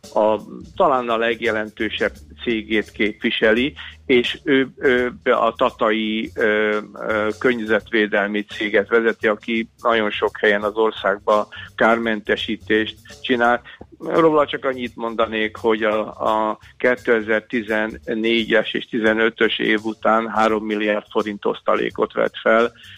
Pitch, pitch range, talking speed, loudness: 110 Hz, 105-115 Hz, 105 wpm, -20 LUFS